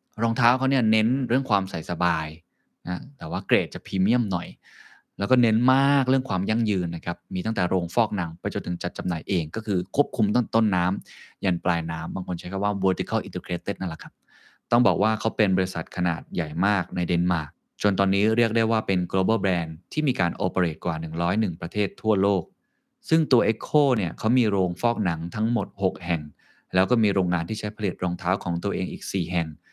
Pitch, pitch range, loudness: 95 Hz, 90-110 Hz, -25 LUFS